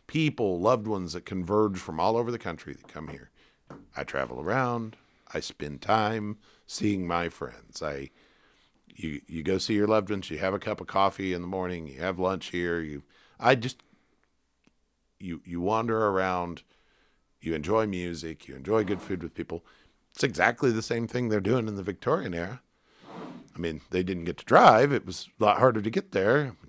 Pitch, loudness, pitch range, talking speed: 95 Hz, -28 LUFS, 85-110 Hz, 190 wpm